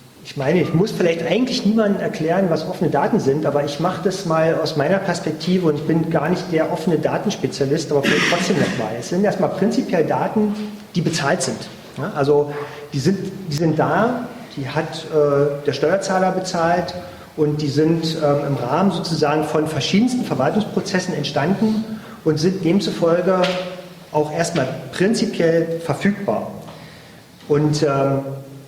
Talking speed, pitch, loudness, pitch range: 150 wpm, 165 Hz, -19 LUFS, 150-190 Hz